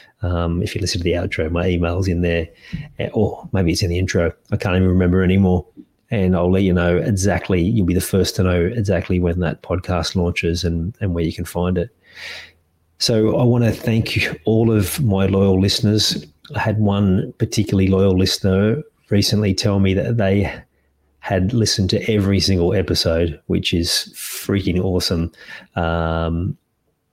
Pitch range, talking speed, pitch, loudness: 85-100 Hz, 175 wpm, 95 Hz, -18 LUFS